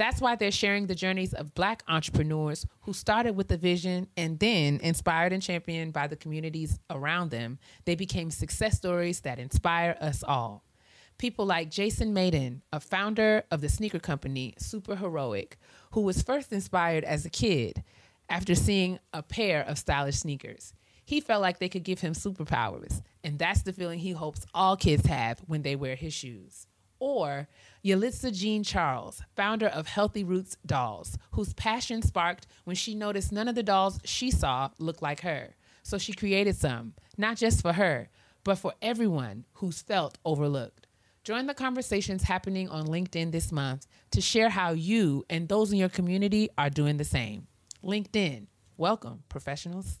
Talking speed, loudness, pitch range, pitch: 170 wpm, -29 LUFS, 140-200 Hz, 170 Hz